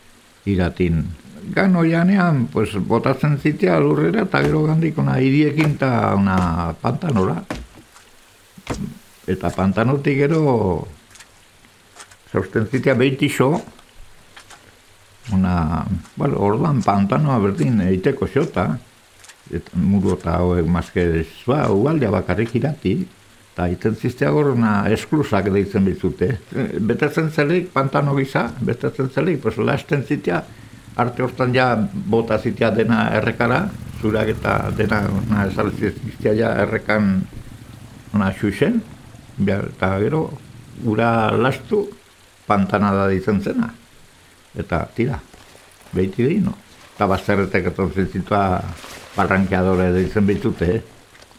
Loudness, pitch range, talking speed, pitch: -19 LUFS, 95-130 Hz, 105 wpm, 110 Hz